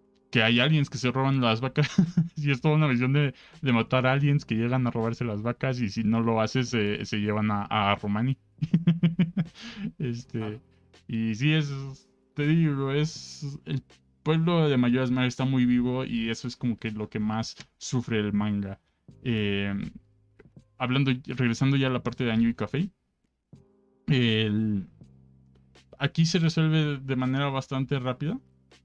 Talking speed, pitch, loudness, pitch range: 160 wpm, 125 Hz, -27 LUFS, 110-140 Hz